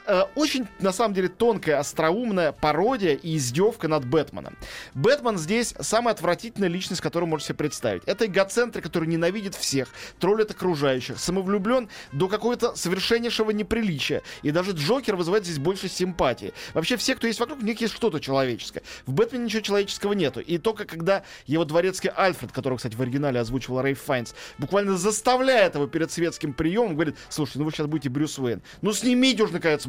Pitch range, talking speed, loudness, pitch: 150-220 Hz, 175 wpm, -25 LUFS, 185 Hz